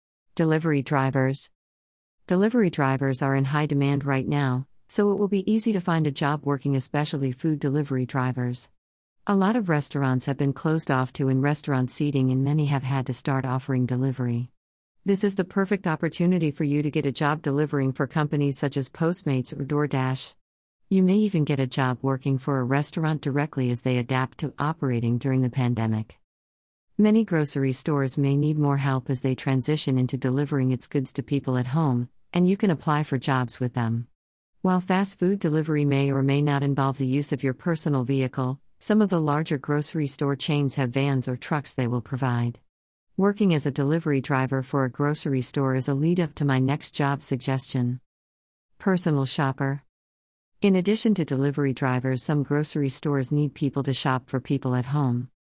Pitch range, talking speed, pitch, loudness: 130-150 Hz, 185 wpm, 140 Hz, -25 LUFS